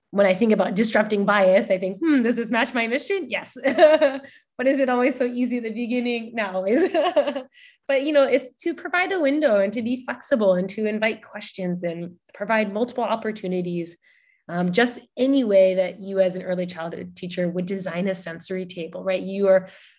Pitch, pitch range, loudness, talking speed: 220 Hz, 190-260 Hz, -22 LUFS, 195 wpm